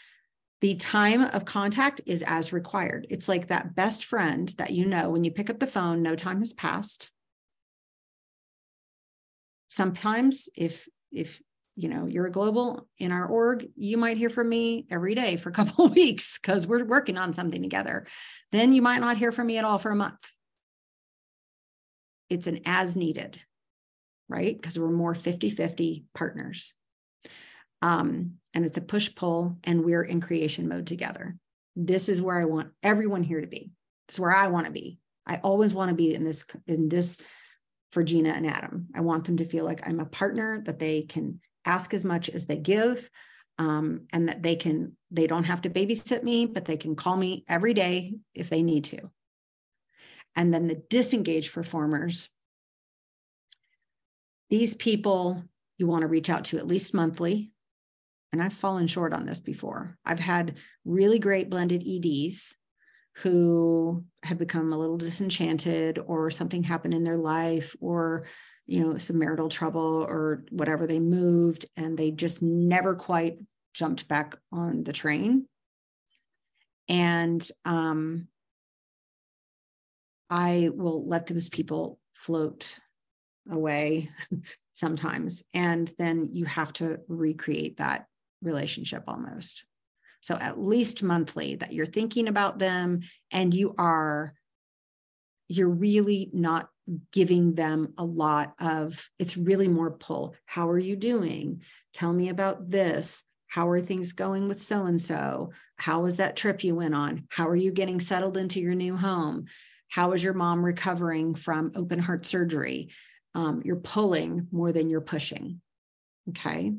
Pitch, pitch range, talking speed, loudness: 175 Hz, 160-195 Hz, 160 wpm, -27 LUFS